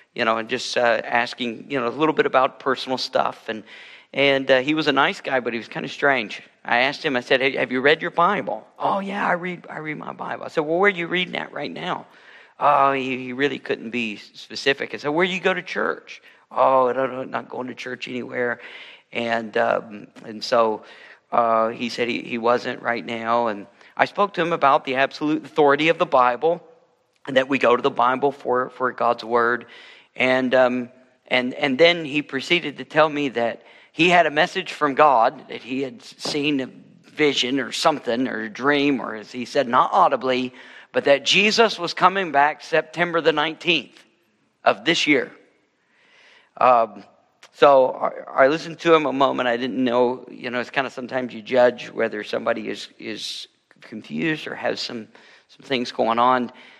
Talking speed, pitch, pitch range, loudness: 205 wpm, 135 Hz, 125-155 Hz, -21 LUFS